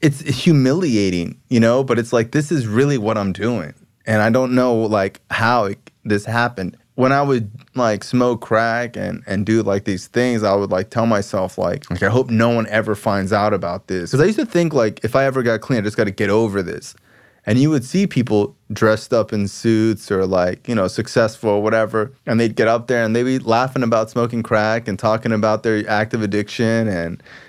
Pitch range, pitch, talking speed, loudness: 105-125 Hz, 115 Hz, 225 wpm, -18 LUFS